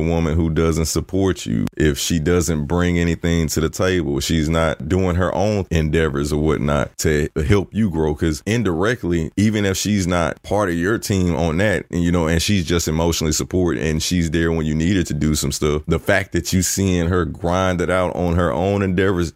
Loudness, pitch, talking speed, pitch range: -19 LUFS, 85 Hz, 215 wpm, 80-95 Hz